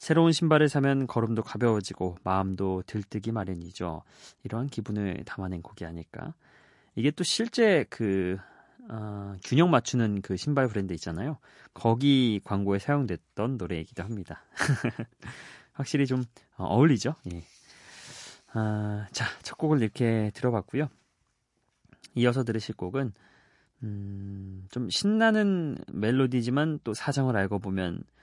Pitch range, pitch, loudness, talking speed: 95-135 Hz, 110 Hz, -28 LUFS, 270 characters per minute